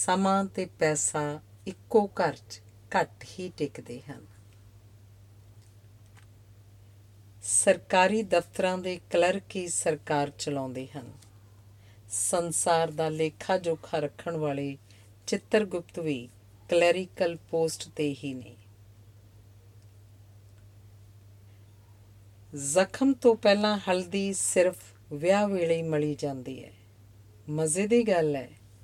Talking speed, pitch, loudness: 100 wpm, 140 Hz, -28 LUFS